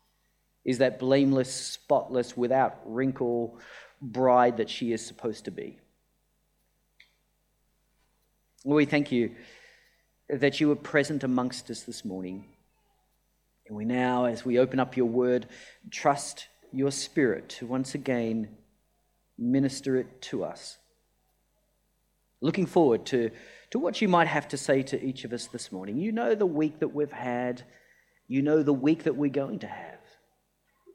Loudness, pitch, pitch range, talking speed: -28 LUFS, 130 Hz, 120-145 Hz, 145 wpm